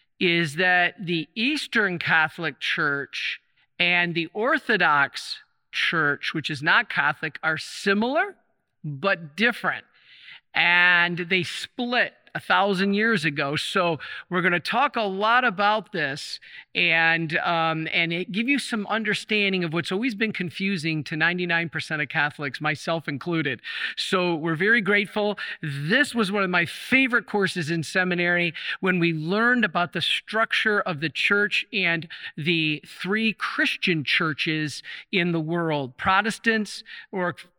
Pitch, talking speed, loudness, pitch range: 180 Hz, 135 wpm, -23 LUFS, 165-210 Hz